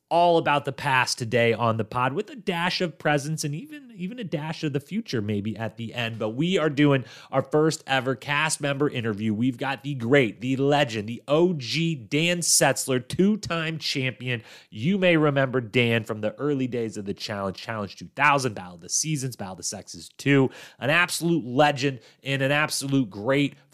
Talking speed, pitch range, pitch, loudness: 195 wpm, 115-155 Hz, 135 Hz, -24 LUFS